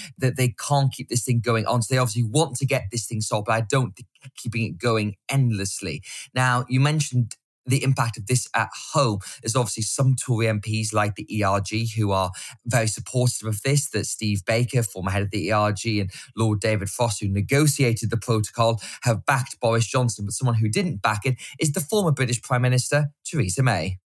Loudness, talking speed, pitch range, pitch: -23 LUFS, 205 wpm, 110-130 Hz, 120 Hz